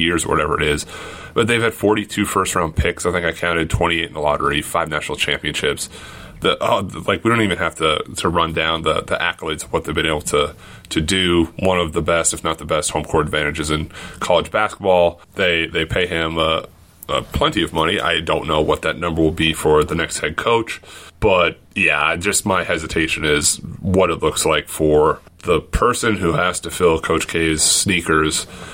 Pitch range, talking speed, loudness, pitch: 80-95 Hz, 215 wpm, -18 LUFS, 85 Hz